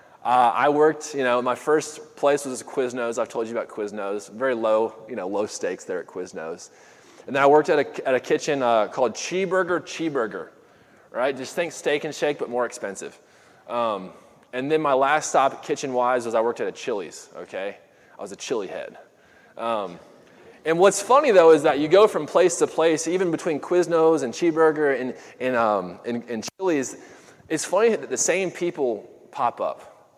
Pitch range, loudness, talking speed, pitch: 125-180 Hz, -23 LUFS, 195 wpm, 155 Hz